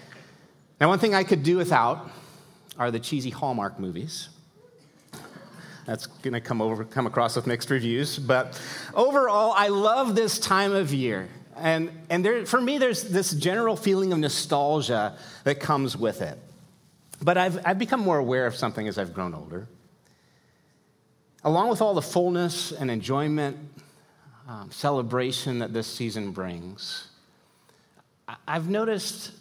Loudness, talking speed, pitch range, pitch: -25 LUFS, 145 wpm, 125-185 Hz, 150 Hz